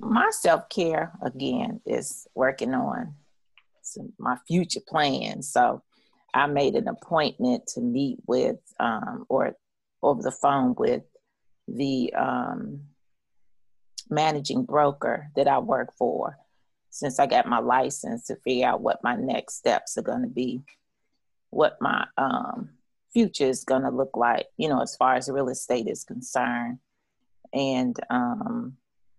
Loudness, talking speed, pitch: -26 LUFS, 135 wpm, 140 Hz